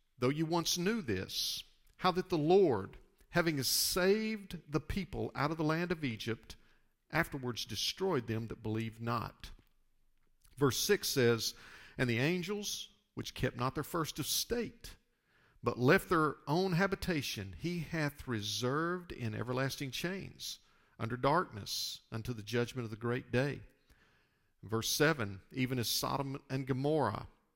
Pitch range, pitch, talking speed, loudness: 120-175 Hz, 140 Hz, 140 wpm, -35 LUFS